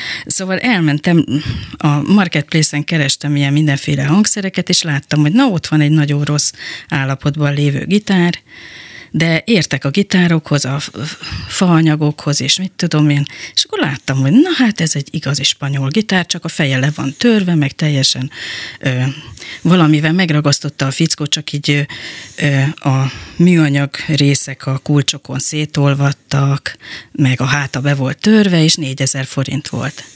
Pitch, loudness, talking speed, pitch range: 150 Hz, -14 LUFS, 145 wpm, 140-165 Hz